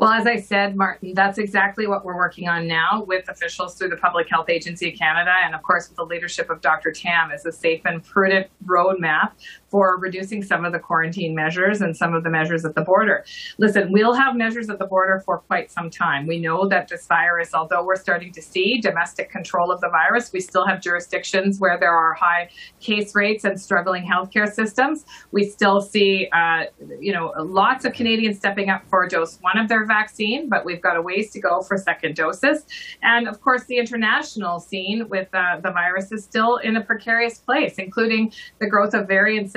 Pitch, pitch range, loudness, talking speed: 190 Hz, 175-215 Hz, -20 LUFS, 210 wpm